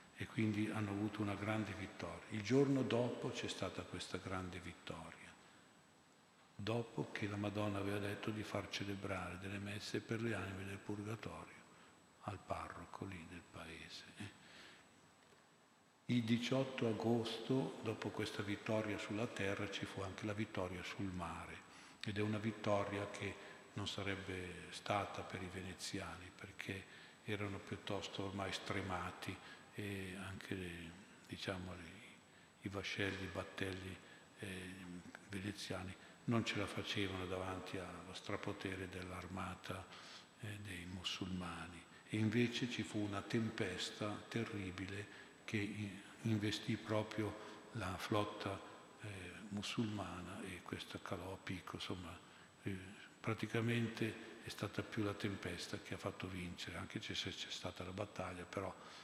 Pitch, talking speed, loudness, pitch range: 100 Hz, 125 wpm, -44 LUFS, 95-110 Hz